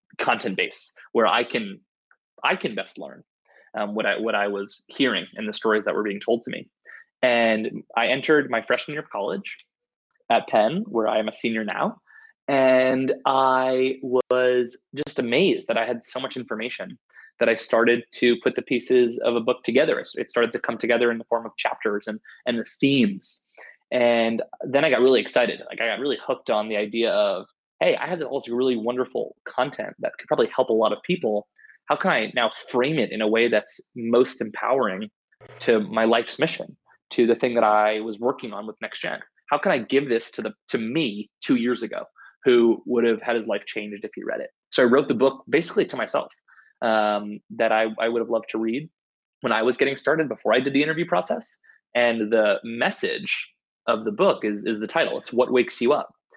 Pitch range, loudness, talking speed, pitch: 110-130 Hz, -23 LUFS, 215 wpm, 120 Hz